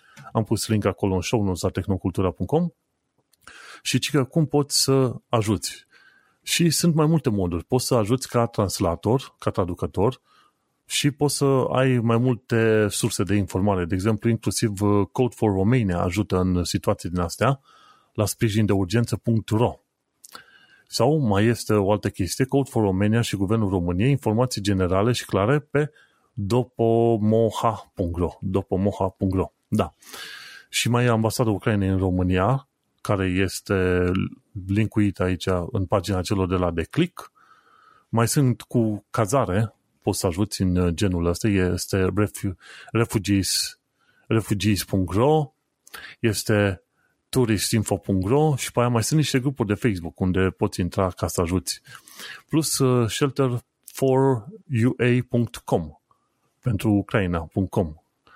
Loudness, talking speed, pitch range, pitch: -23 LUFS, 120 wpm, 95-125 Hz, 110 Hz